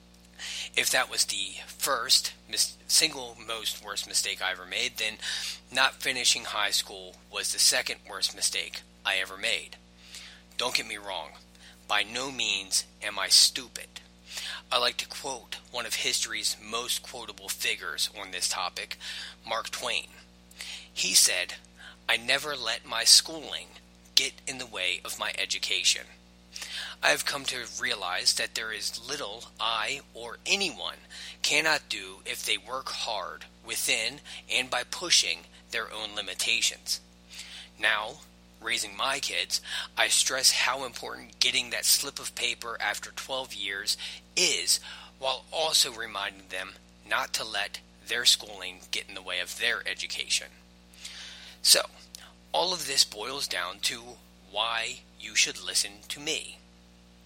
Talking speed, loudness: 145 wpm, -27 LUFS